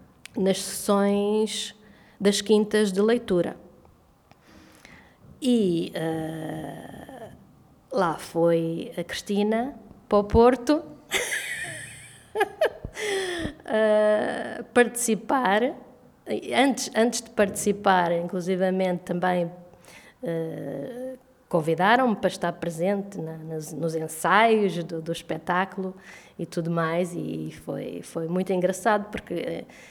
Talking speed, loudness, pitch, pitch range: 85 wpm, -25 LUFS, 195 Hz, 170-220 Hz